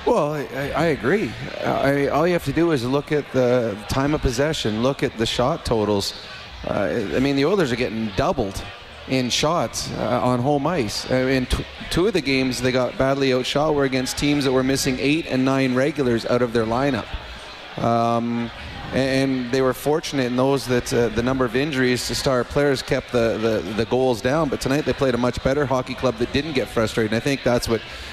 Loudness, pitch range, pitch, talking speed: -21 LUFS, 120-140 Hz, 130 Hz, 220 wpm